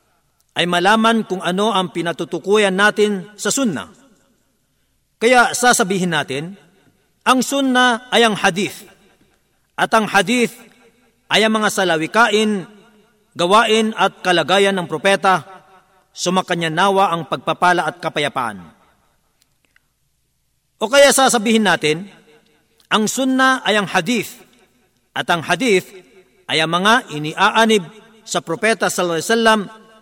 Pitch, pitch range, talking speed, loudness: 195 Hz, 175-220 Hz, 110 wpm, -16 LUFS